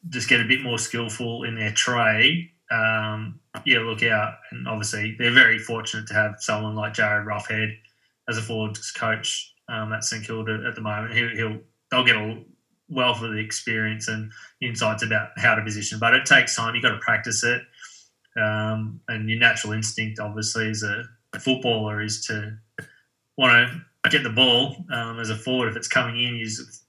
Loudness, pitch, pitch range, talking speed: -22 LUFS, 110 Hz, 110-120 Hz, 190 wpm